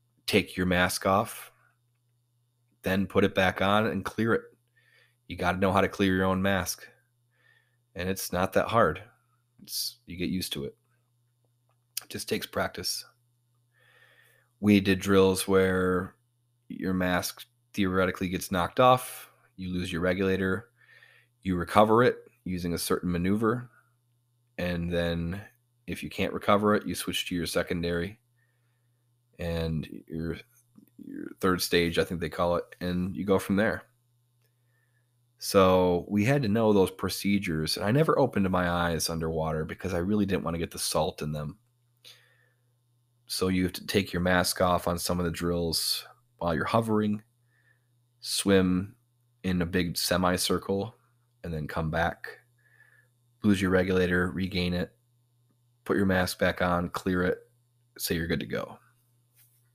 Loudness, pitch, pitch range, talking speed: -28 LUFS, 100 Hz, 90-120 Hz, 155 wpm